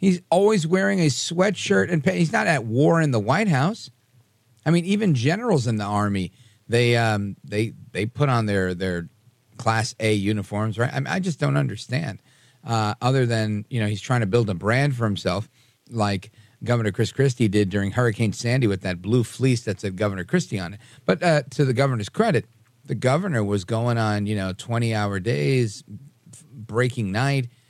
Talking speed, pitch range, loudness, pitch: 195 wpm, 105-140 Hz, -23 LUFS, 120 Hz